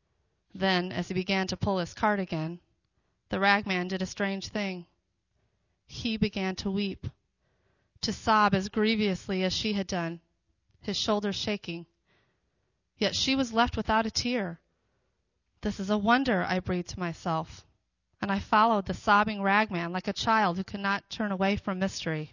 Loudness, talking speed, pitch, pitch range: -28 LUFS, 165 wpm, 195 Hz, 180-210 Hz